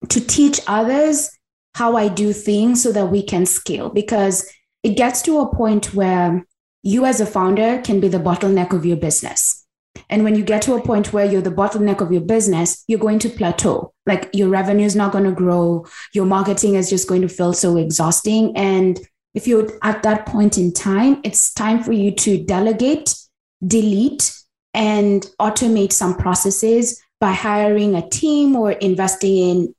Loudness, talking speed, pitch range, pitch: -17 LUFS, 185 wpm, 190-225 Hz, 205 Hz